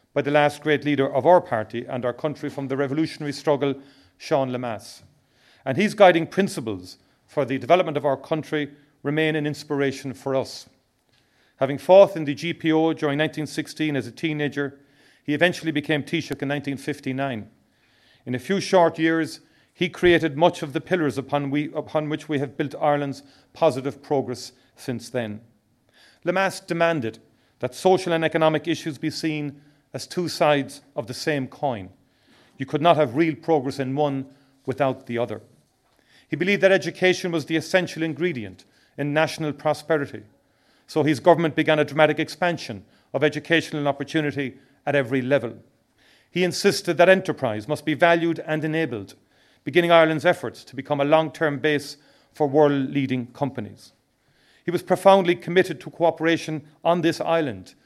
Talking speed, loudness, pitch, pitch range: 160 wpm, -23 LUFS, 150 Hz, 135-160 Hz